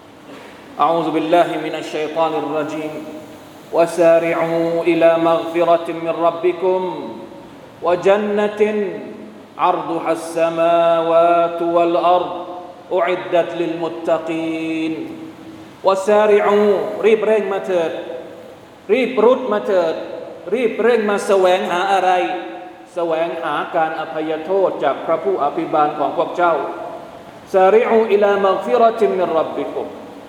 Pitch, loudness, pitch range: 170 Hz, -17 LUFS, 165-190 Hz